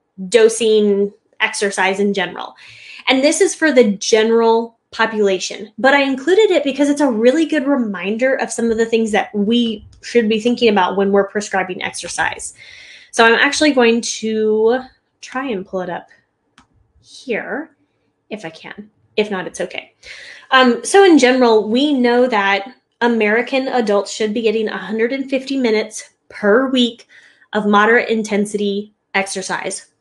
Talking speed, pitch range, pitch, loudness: 150 wpm, 205-250 Hz, 225 Hz, -16 LUFS